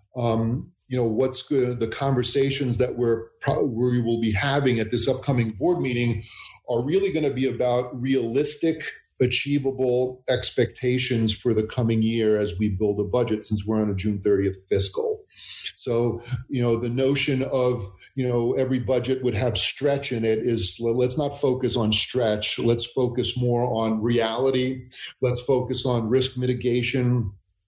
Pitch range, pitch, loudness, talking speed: 115-130 Hz, 125 Hz, -24 LUFS, 165 wpm